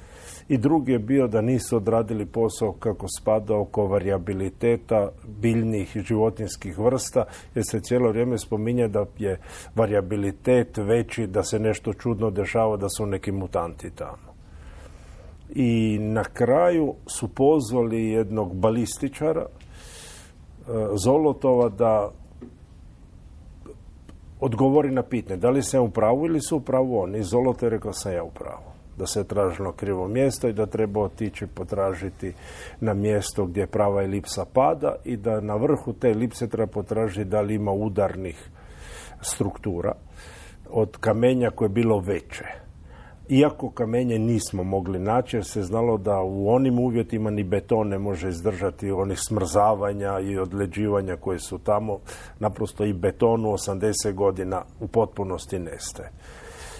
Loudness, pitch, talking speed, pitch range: -24 LUFS, 105 Hz, 135 wpm, 95-115 Hz